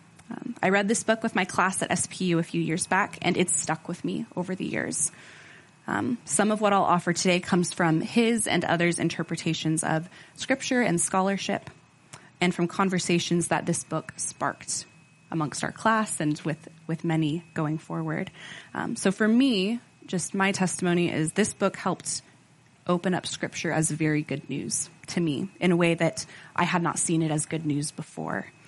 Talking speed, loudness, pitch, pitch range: 185 wpm, -26 LUFS, 170 Hz, 160-190 Hz